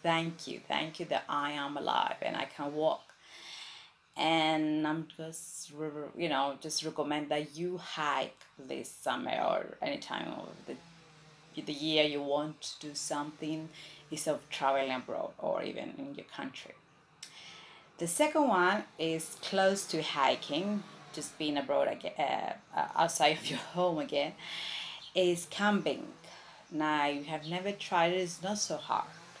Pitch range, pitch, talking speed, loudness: 150-180 Hz, 155 Hz, 150 wpm, -33 LUFS